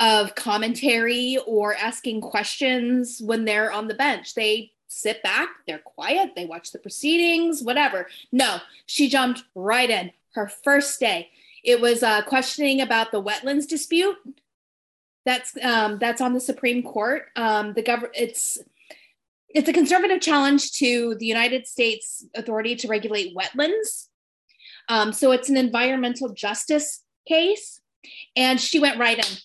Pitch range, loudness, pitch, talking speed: 220-275 Hz, -22 LUFS, 245 Hz, 145 wpm